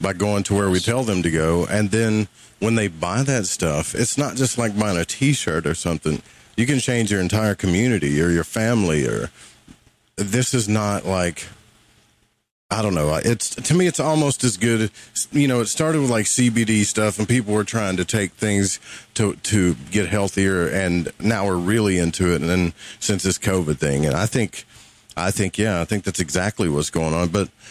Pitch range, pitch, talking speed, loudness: 90-115 Hz, 105 Hz, 210 wpm, -20 LUFS